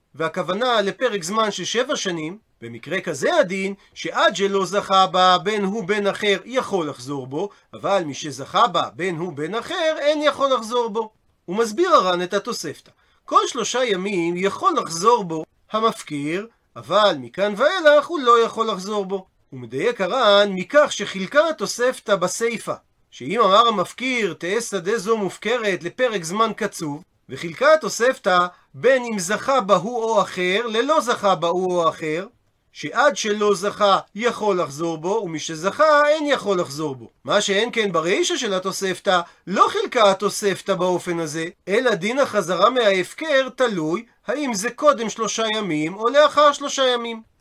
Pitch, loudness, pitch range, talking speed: 205 Hz, -20 LUFS, 180-240 Hz, 150 wpm